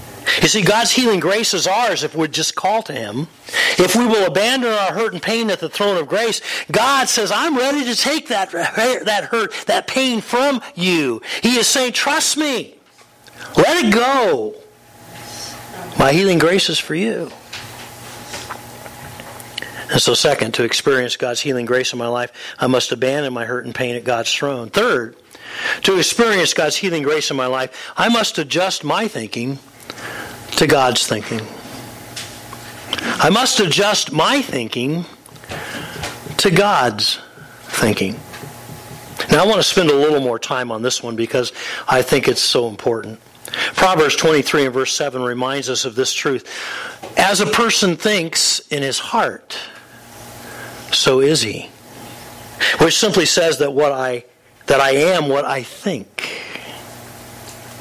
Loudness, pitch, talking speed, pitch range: -16 LUFS, 170 Hz, 155 wpm, 130-225 Hz